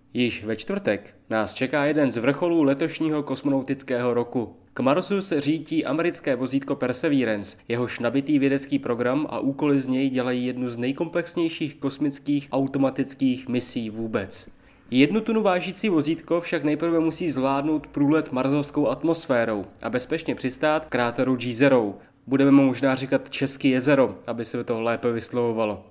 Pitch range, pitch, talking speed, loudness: 125-155 Hz, 135 Hz, 145 wpm, -24 LUFS